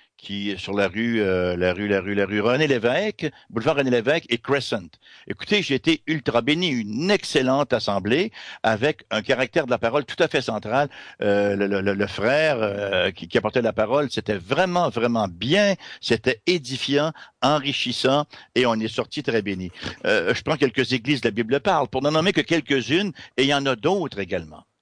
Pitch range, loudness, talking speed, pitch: 110-155 Hz, -22 LUFS, 195 wpm, 130 Hz